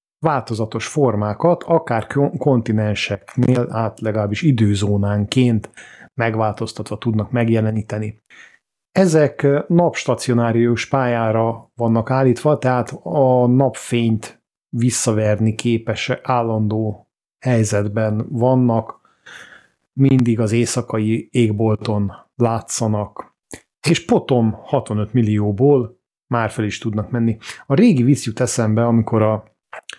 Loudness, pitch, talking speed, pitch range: -18 LUFS, 115 Hz, 85 wpm, 110-130 Hz